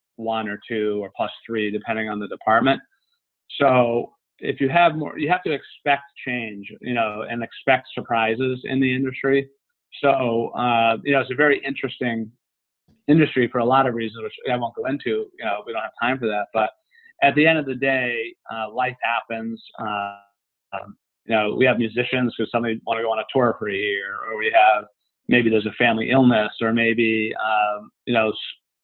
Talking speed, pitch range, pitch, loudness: 200 wpm, 110-135 Hz, 120 Hz, -21 LUFS